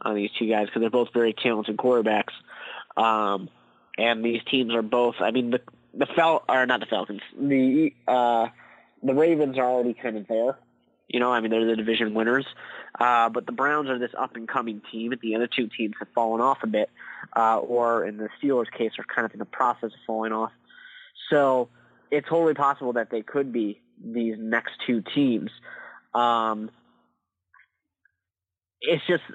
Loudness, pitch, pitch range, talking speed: -25 LUFS, 115 Hz, 110-130 Hz, 190 wpm